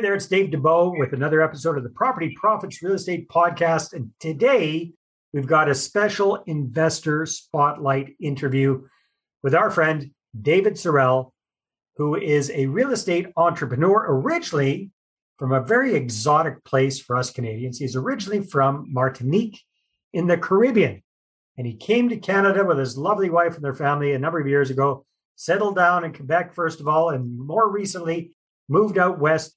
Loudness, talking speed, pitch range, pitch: -21 LUFS, 165 wpm, 135-180 Hz, 155 Hz